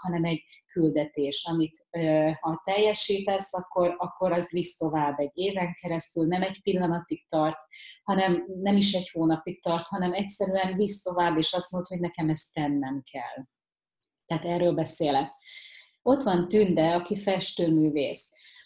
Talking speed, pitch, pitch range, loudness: 140 wpm, 175 Hz, 160-190 Hz, -27 LUFS